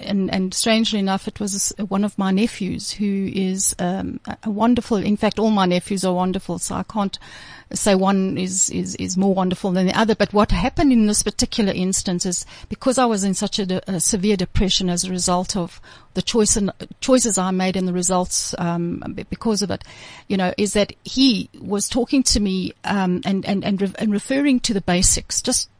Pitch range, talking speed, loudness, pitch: 185-215 Hz, 210 wpm, -20 LUFS, 195 Hz